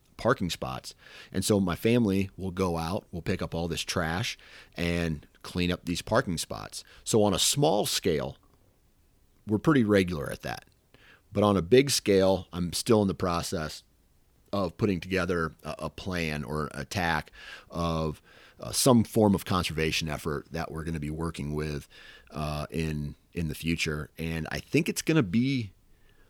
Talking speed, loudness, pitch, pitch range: 170 wpm, -28 LUFS, 85 Hz, 80-95 Hz